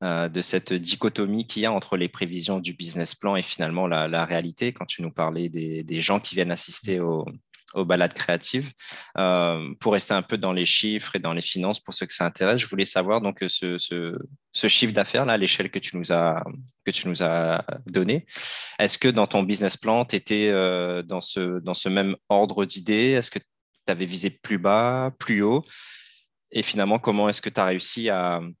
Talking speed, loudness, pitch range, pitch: 205 wpm, -24 LUFS, 85-105 Hz, 95 Hz